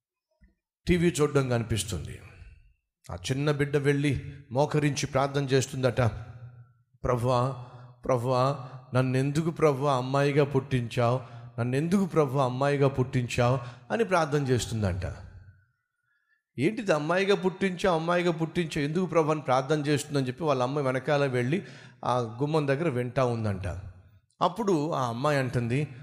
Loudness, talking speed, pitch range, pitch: -27 LUFS, 105 wpm, 125-150 Hz, 135 Hz